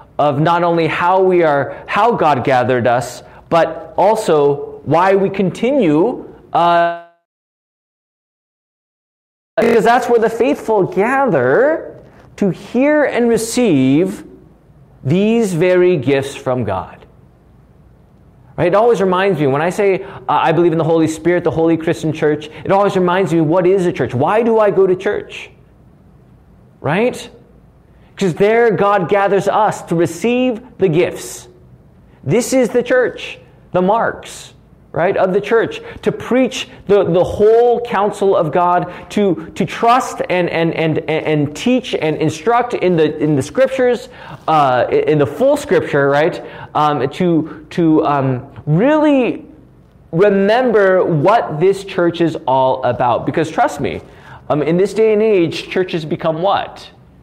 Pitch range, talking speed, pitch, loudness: 155-215 Hz, 145 wpm, 180 Hz, -14 LUFS